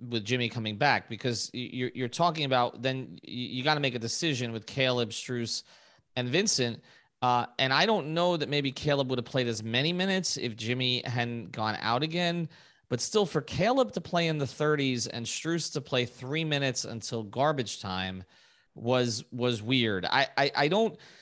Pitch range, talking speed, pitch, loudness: 120-150 Hz, 185 wpm, 125 Hz, -29 LUFS